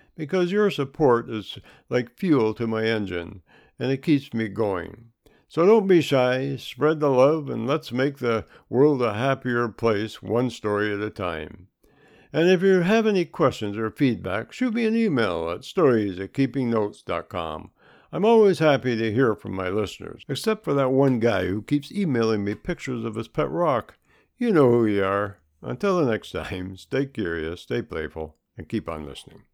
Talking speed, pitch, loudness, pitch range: 180 wpm, 120 Hz, -23 LUFS, 105-145 Hz